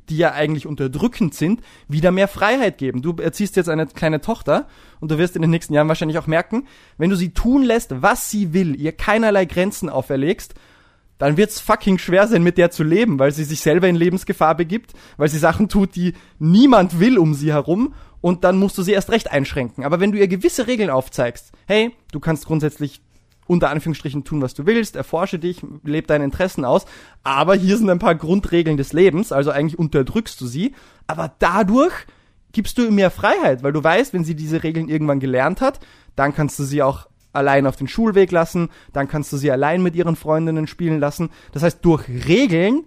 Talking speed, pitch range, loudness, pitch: 210 wpm, 150-195 Hz, -18 LUFS, 165 Hz